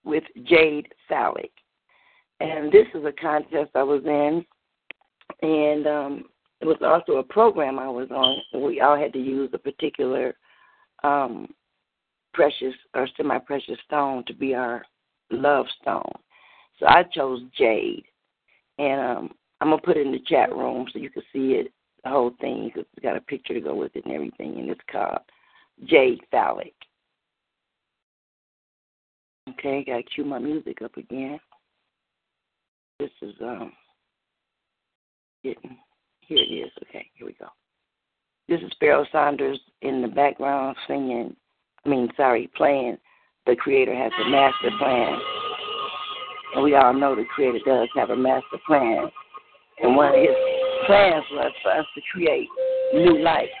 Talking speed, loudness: 150 wpm, -22 LUFS